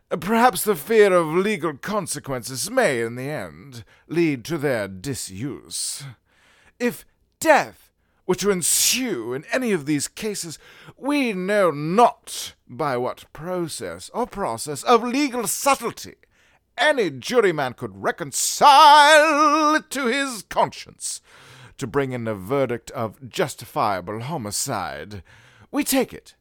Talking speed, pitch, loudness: 125 wpm, 180 Hz, -21 LUFS